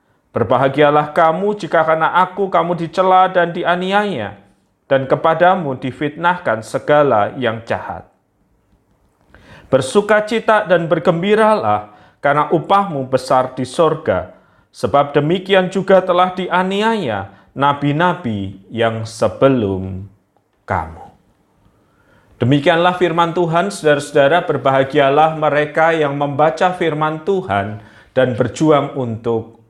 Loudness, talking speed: -15 LUFS, 90 wpm